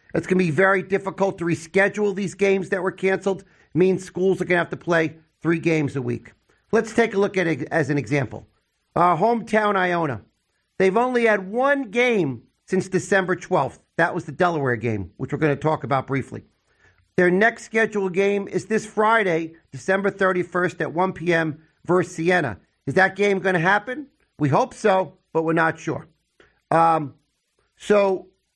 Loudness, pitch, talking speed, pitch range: -22 LUFS, 180 Hz, 185 wpm, 155-195 Hz